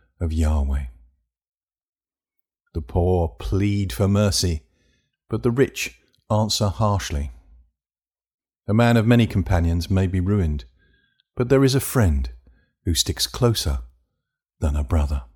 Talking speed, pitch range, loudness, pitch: 120 wpm, 75-105 Hz, -22 LUFS, 85 Hz